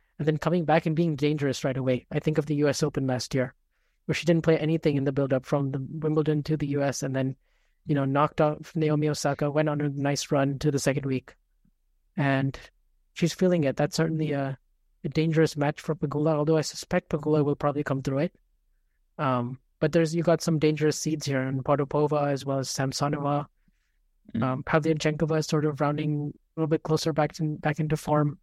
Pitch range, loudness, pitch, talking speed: 140-155 Hz, -27 LUFS, 150 Hz, 210 wpm